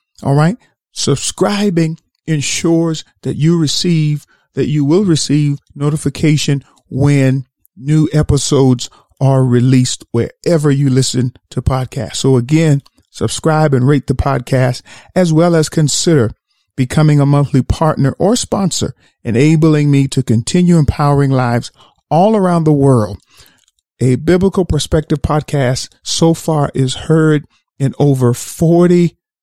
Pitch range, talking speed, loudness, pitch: 130-160 Hz, 120 wpm, -13 LUFS, 145 Hz